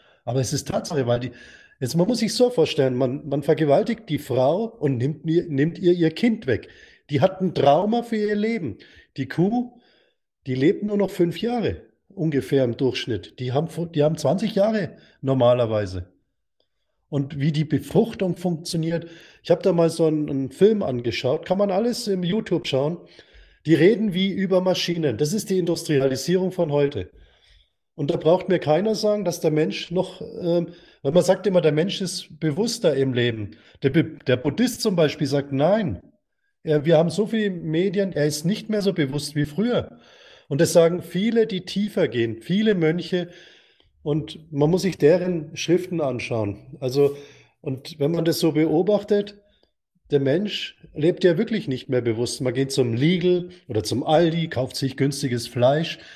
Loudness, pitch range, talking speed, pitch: -22 LUFS, 140-190 Hz, 175 wpm, 165 Hz